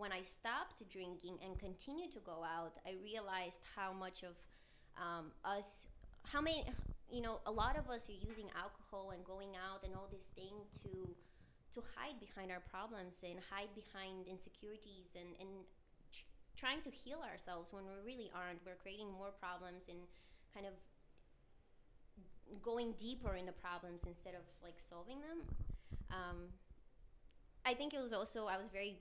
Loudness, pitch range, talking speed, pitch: -49 LUFS, 180-210 Hz, 170 wpm, 190 Hz